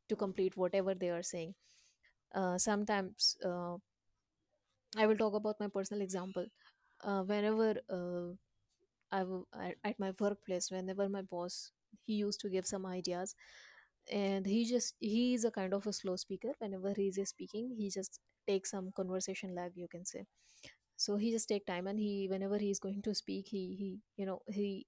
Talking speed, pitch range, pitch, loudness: 185 wpm, 185-210 Hz, 195 Hz, -38 LUFS